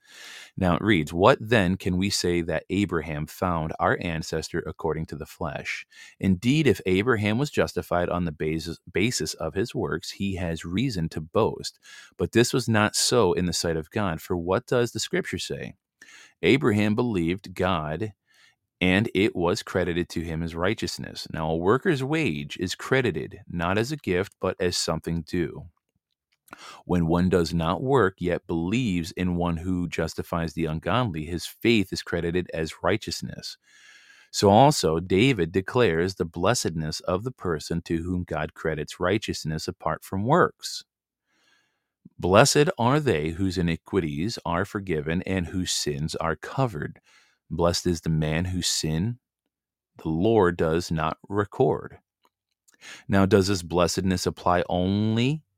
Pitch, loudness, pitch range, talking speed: 90 Hz, -25 LUFS, 85-100 Hz, 150 wpm